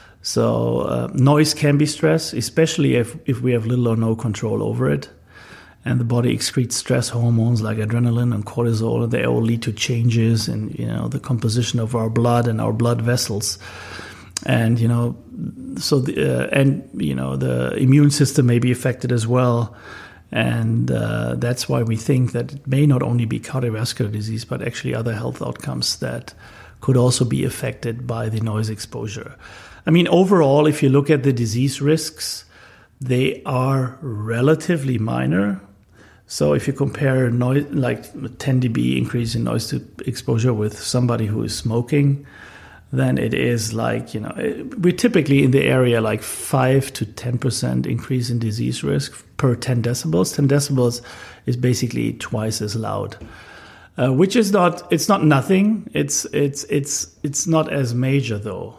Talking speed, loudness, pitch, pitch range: 170 wpm, -20 LUFS, 120 Hz, 110-140 Hz